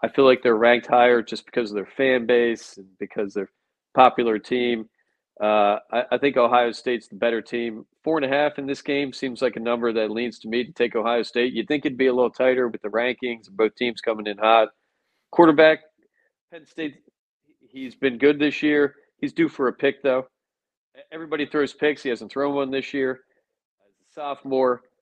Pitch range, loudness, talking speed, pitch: 115-140 Hz, -22 LUFS, 210 wpm, 125 Hz